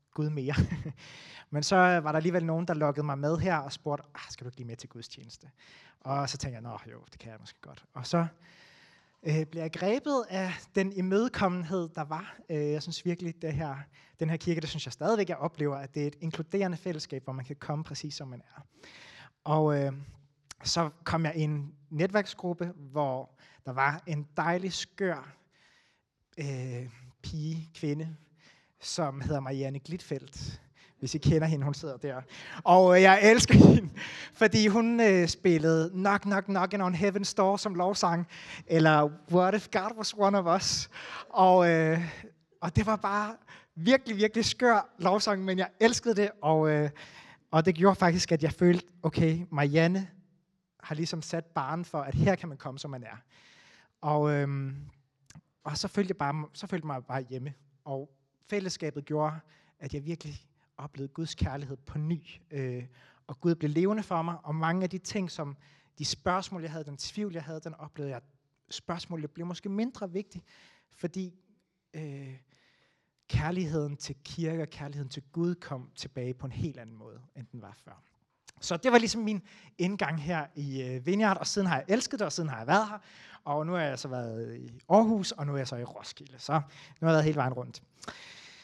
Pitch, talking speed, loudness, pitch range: 160 Hz, 190 wpm, -29 LUFS, 145-185 Hz